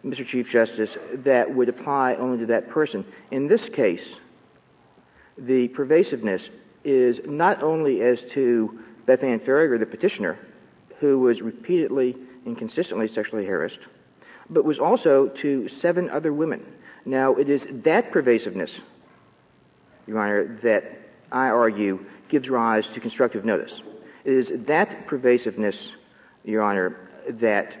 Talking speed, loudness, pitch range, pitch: 130 wpm, -23 LUFS, 115-140 Hz, 125 Hz